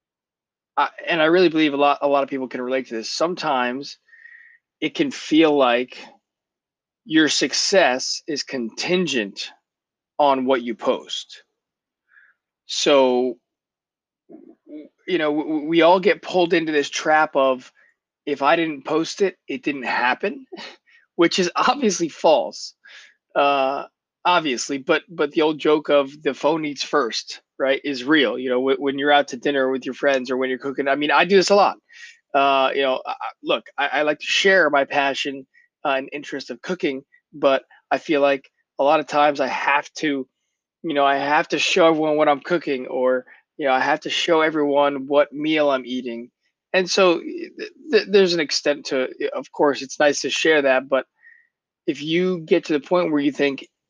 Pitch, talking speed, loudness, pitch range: 150 Hz, 180 wpm, -20 LUFS, 135-175 Hz